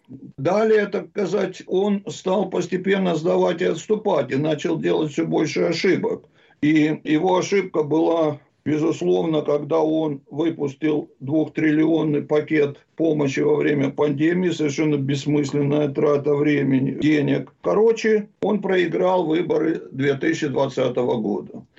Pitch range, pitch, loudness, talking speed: 150-180 Hz, 155 Hz, -21 LUFS, 110 wpm